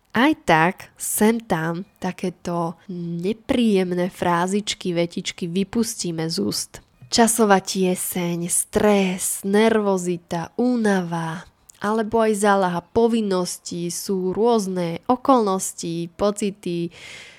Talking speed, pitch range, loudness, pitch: 85 wpm, 175-215 Hz, -21 LUFS, 190 Hz